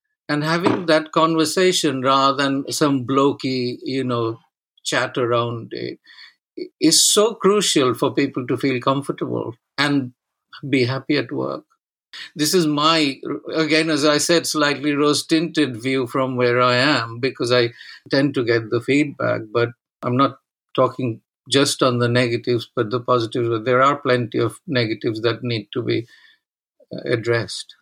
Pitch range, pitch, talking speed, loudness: 120-150 Hz, 135 Hz, 145 wpm, -19 LUFS